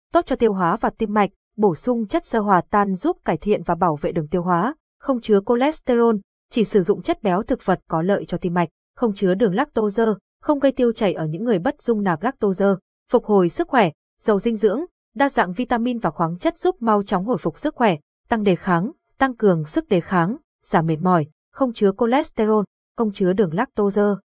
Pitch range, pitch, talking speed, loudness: 185-245 Hz, 210 Hz, 220 wpm, -21 LUFS